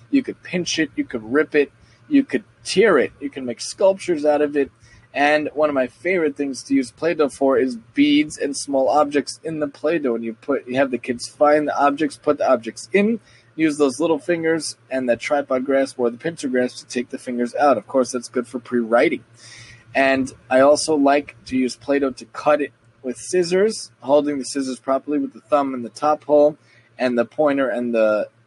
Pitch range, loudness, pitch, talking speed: 120-150 Hz, -20 LUFS, 135 Hz, 215 wpm